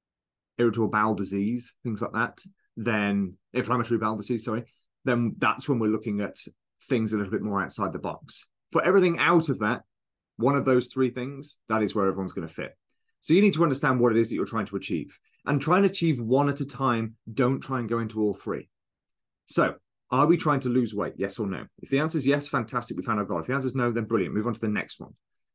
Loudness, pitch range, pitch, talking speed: -26 LUFS, 110-140 Hz, 120 Hz, 240 wpm